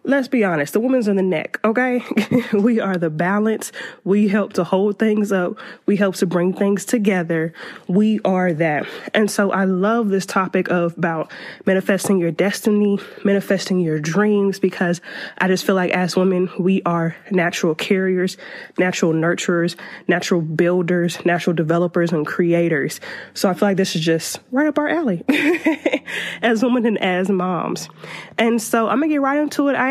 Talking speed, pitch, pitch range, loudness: 175 wpm, 195 Hz, 180-215 Hz, -19 LUFS